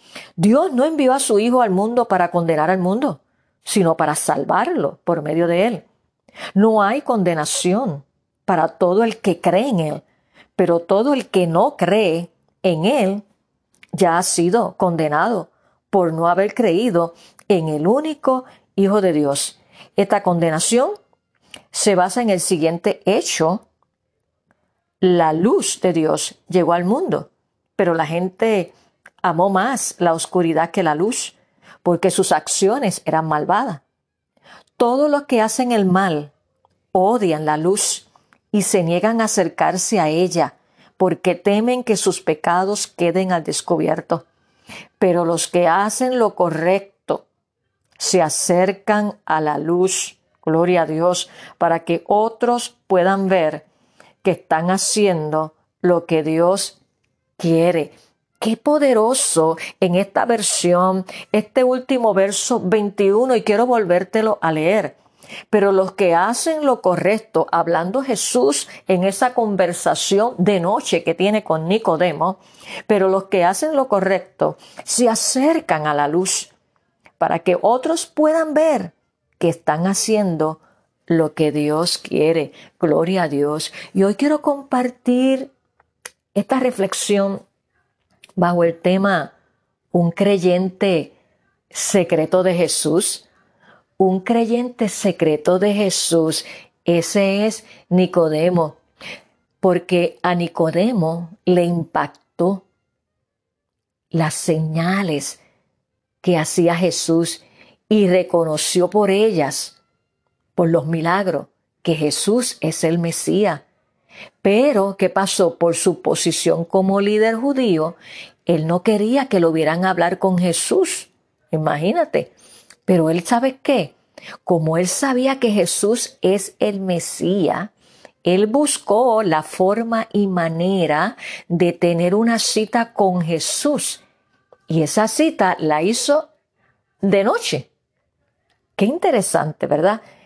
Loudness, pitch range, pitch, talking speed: -18 LUFS, 170-215 Hz, 185 Hz, 120 wpm